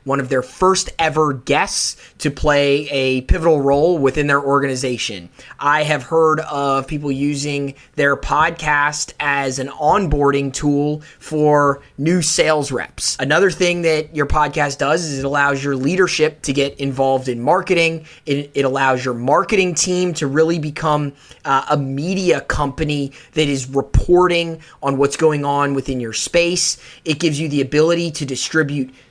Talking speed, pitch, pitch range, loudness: 155 wpm, 145 Hz, 140-155 Hz, -17 LUFS